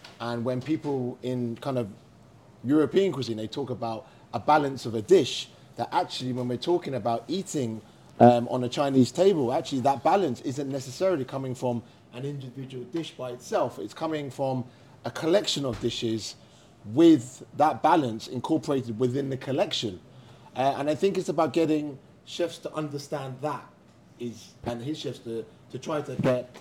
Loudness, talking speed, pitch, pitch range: -27 LUFS, 165 wpm, 130 Hz, 120-150 Hz